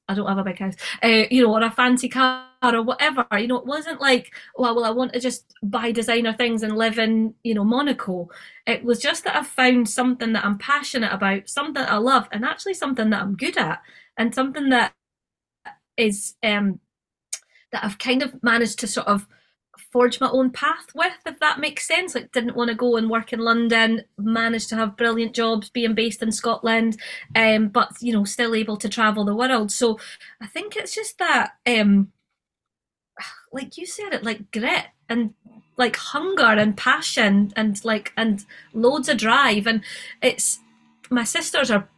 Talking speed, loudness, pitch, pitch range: 195 wpm, -21 LUFS, 230 Hz, 220-255 Hz